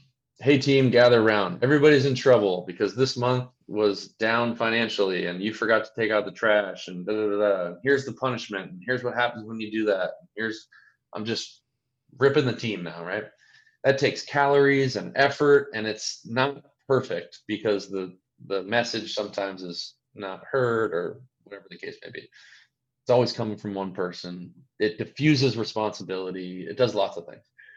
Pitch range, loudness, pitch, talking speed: 105-130 Hz, -25 LUFS, 115 Hz, 175 wpm